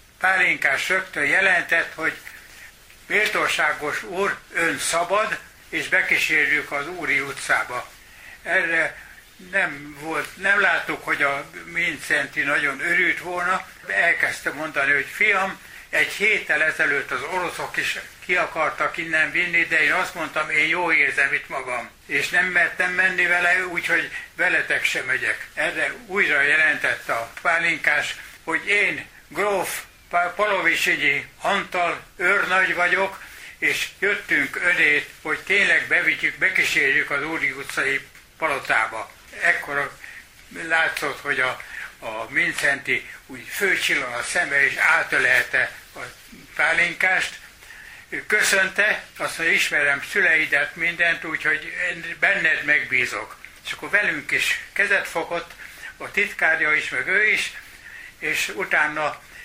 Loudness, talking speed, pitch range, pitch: -20 LUFS, 120 wpm, 160-190 Hz, 175 Hz